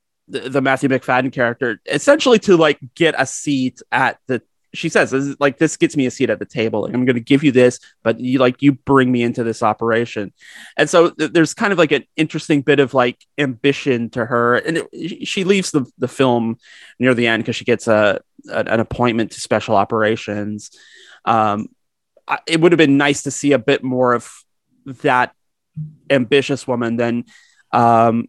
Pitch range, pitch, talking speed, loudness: 120-145 Hz, 130 Hz, 200 wpm, -17 LUFS